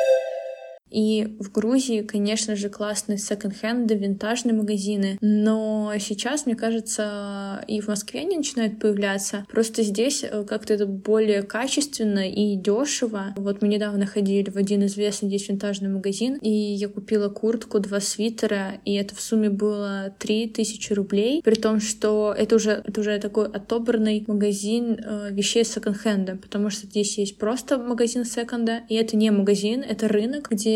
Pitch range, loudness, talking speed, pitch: 205-225 Hz, -24 LUFS, 150 wpm, 210 Hz